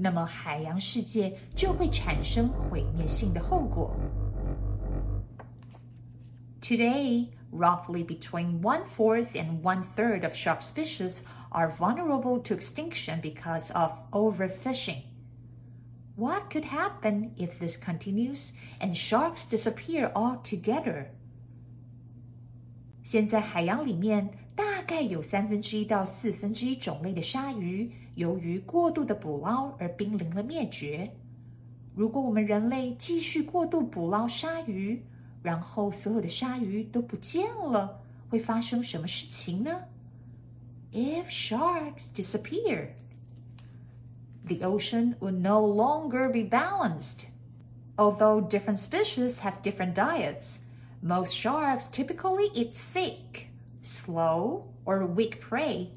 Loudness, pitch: -30 LUFS, 185 Hz